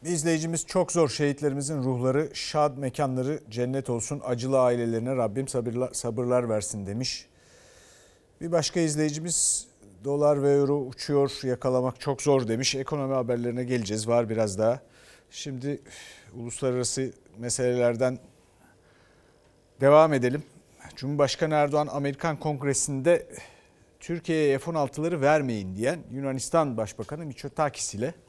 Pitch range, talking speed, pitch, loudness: 125-150 Hz, 110 wpm, 135 Hz, -26 LUFS